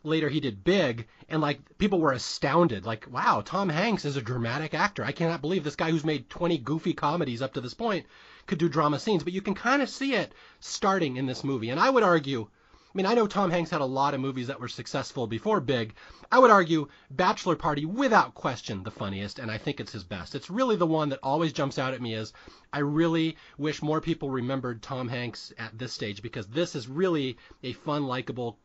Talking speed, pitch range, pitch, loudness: 230 wpm, 125-170 Hz, 145 Hz, -28 LUFS